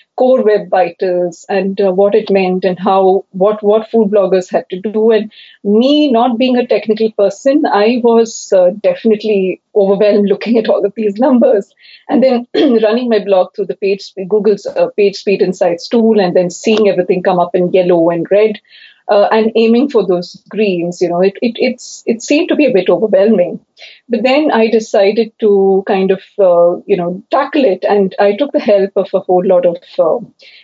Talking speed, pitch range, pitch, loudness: 195 wpm, 190-225 Hz, 205 Hz, -12 LUFS